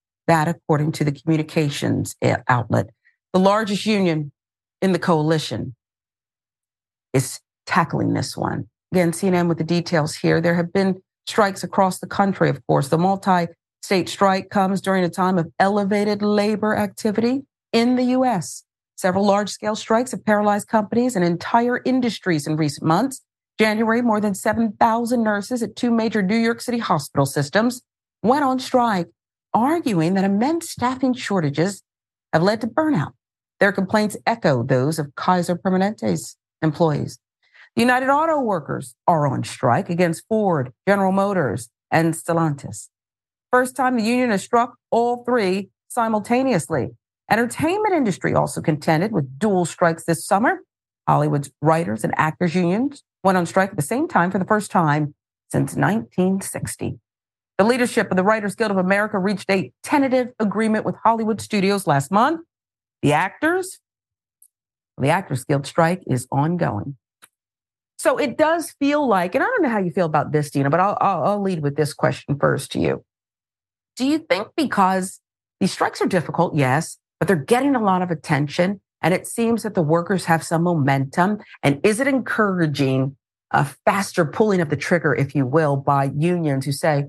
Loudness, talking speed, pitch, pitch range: -20 LUFS, 160 wpm, 185 Hz, 155-215 Hz